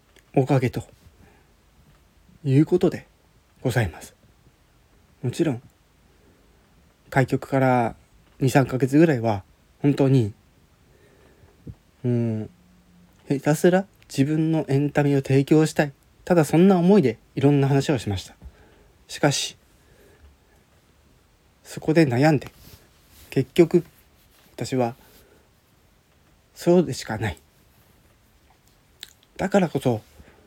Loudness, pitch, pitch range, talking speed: -22 LUFS, 130 Hz, 100-150 Hz, 185 characters per minute